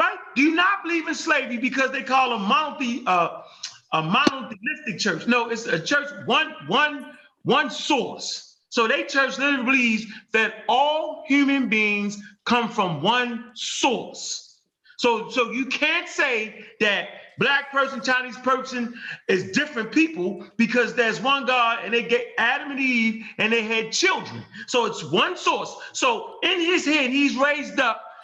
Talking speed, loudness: 155 wpm, -22 LUFS